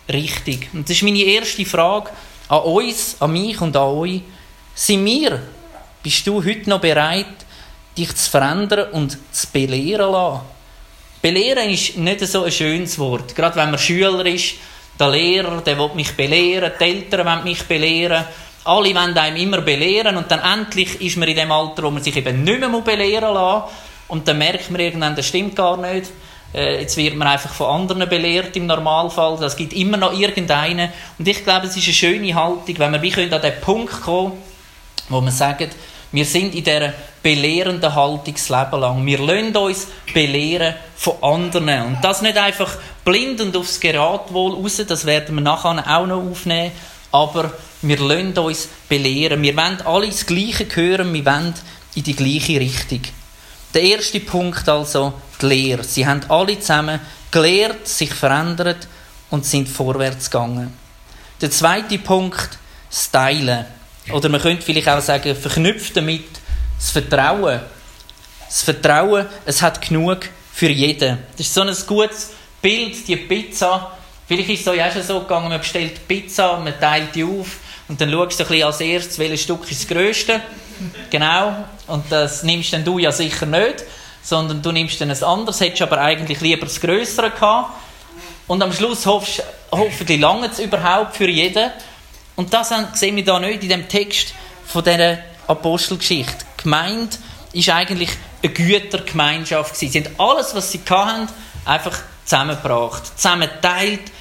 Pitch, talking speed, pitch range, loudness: 170 Hz, 170 wpm, 150-190 Hz, -17 LUFS